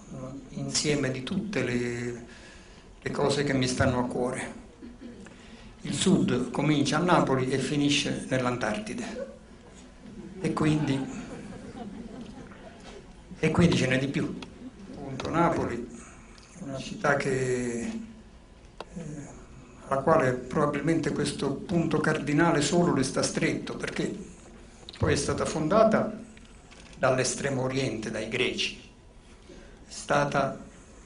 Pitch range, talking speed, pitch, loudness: 130-195 Hz, 105 wpm, 150 Hz, -27 LUFS